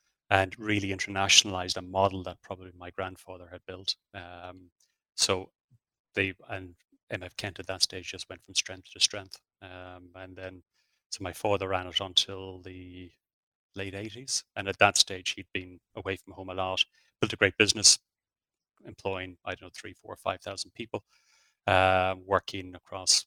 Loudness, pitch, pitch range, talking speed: -28 LUFS, 95 Hz, 90-95 Hz, 170 wpm